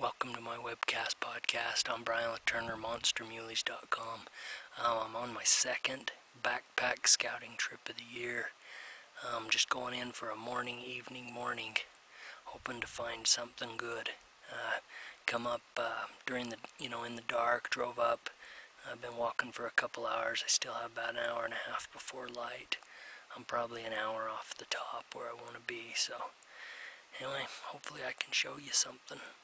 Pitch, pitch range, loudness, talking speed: 120 Hz, 115-120 Hz, -36 LUFS, 175 wpm